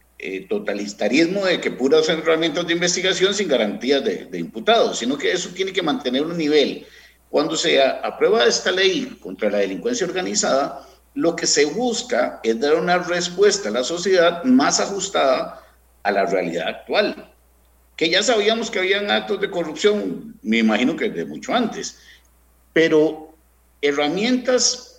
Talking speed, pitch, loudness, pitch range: 150 wpm, 175 Hz, -19 LUFS, 125-210 Hz